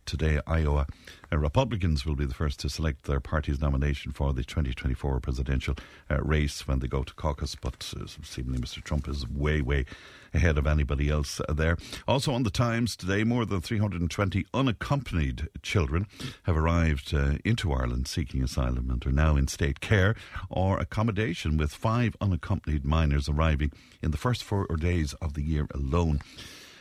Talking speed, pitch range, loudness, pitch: 170 wpm, 70-95 Hz, -29 LUFS, 80 Hz